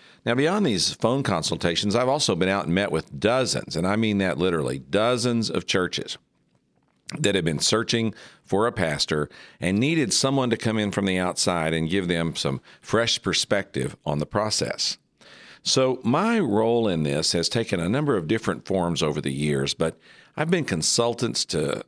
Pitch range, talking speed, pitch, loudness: 80-115 Hz, 180 wpm, 95 Hz, -23 LUFS